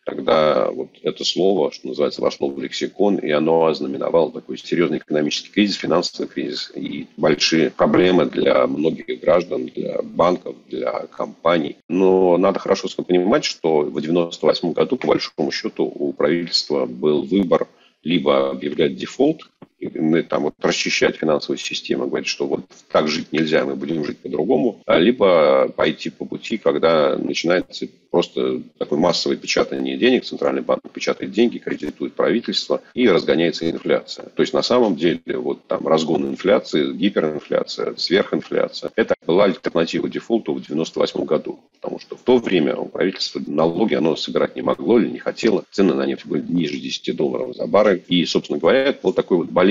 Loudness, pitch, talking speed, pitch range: -19 LUFS, 85 Hz, 160 wpm, 70-95 Hz